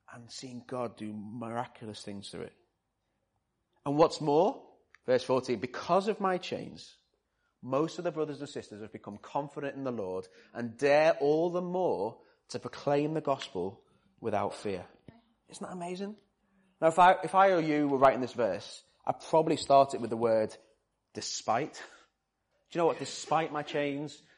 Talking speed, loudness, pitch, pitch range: 170 wpm, -30 LUFS, 145 Hz, 120-165 Hz